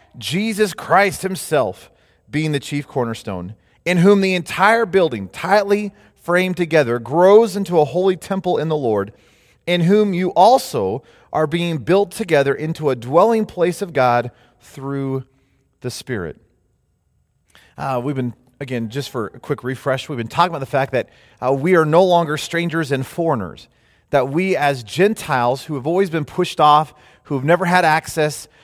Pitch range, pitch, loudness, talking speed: 130-180 Hz, 155 Hz, -18 LUFS, 165 wpm